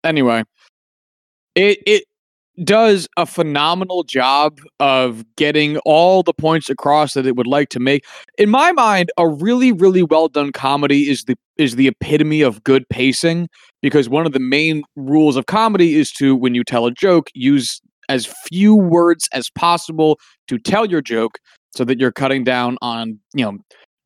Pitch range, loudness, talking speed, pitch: 130-170 Hz, -15 LUFS, 170 wpm, 150 Hz